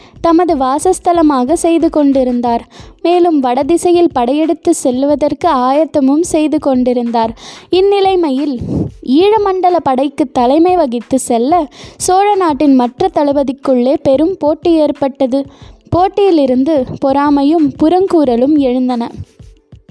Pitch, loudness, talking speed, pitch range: 295 Hz, -12 LUFS, 85 wpm, 265-340 Hz